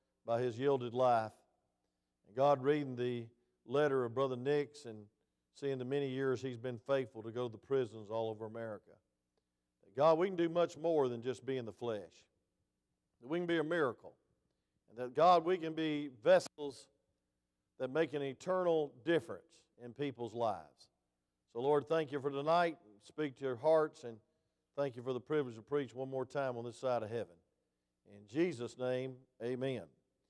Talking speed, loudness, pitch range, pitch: 180 wpm, -37 LUFS, 110-145 Hz, 130 Hz